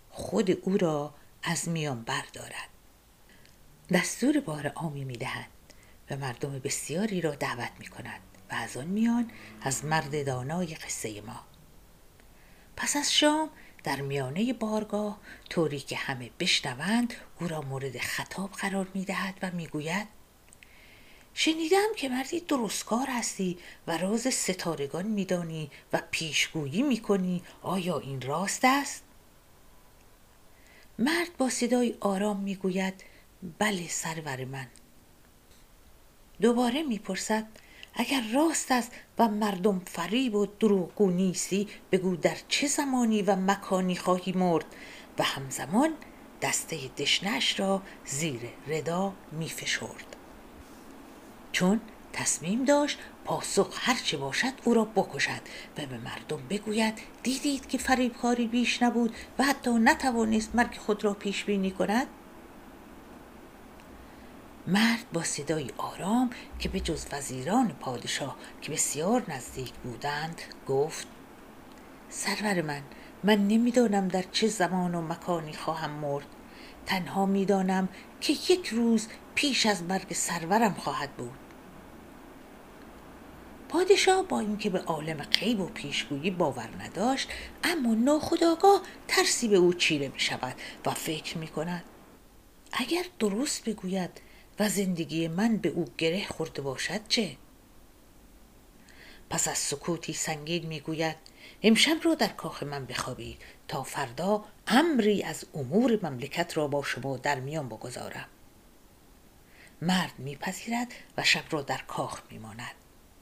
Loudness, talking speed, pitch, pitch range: -29 LUFS, 120 wpm, 190 Hz, 160-235 Hz